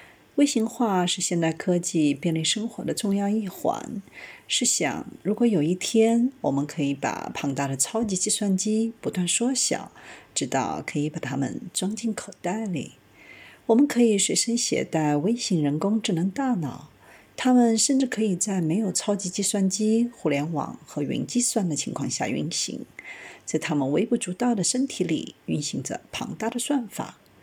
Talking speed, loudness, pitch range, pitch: 250 characters per minute, -25 LUFS, 170-230 Hz, 205 Hz